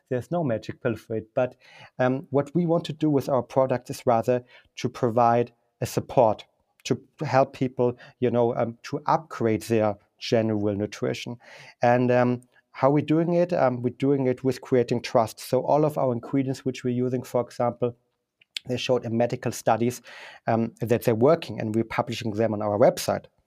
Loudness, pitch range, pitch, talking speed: -25 LUFS, 115-130 Hz, 125 Hz, 185 wpm